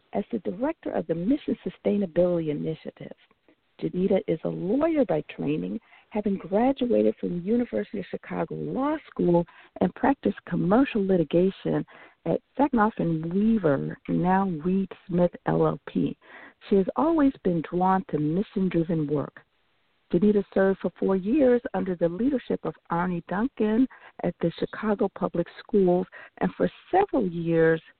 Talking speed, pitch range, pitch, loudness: 135 wpm, 175-240 Hz, 195 Hz, -26 LUFS